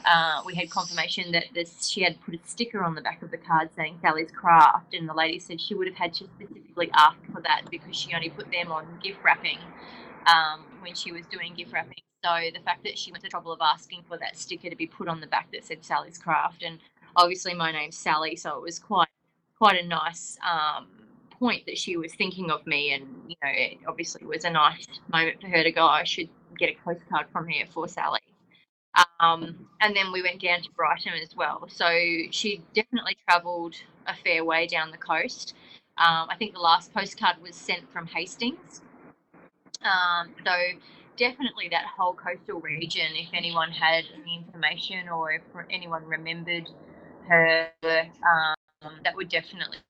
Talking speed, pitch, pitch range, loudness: 200 wpm, 170 Hz, 165-180 Hz, -26 LUFS